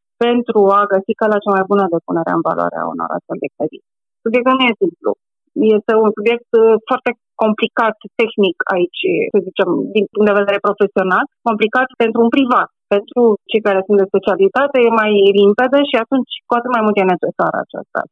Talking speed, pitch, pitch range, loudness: 190 wpm, 220 Hz, 205-245 Hz, -15 LUFS